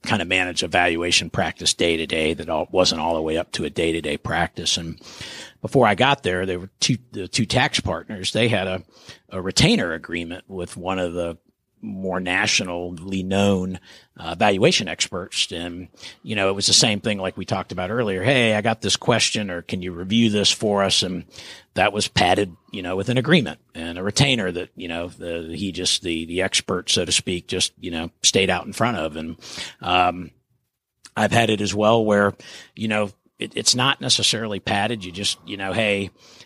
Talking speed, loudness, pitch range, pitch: 210 wpm, -21 LUFS, 90-110 Hz, 95 Hz